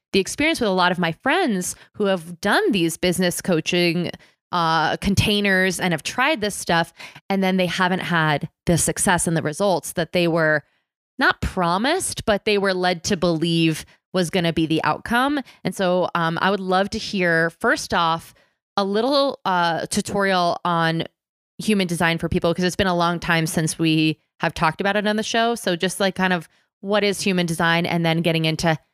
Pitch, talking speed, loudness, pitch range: 180 Hz, 195 wpm, -21 LUFS, 165-200 Hz